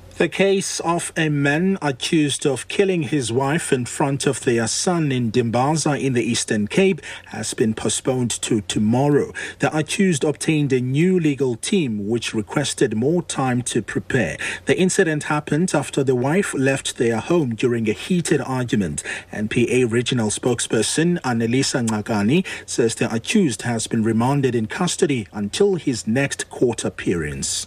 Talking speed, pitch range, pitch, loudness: 150 wpm, 115-155 Hz, 135 Hz, -20 LUFS